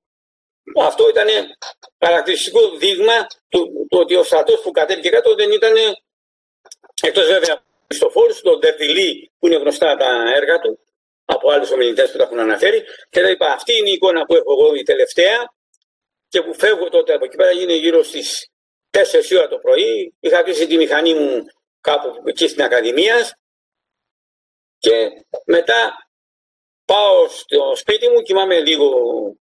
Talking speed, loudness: 155 wpm, -15 LUFS